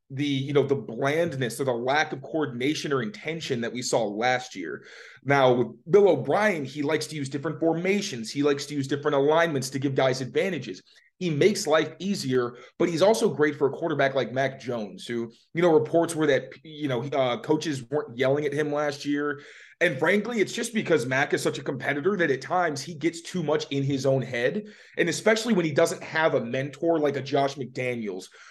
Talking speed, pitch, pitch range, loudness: 210 wpm, 145 Hz, 135-165 Hz, -26 LUFS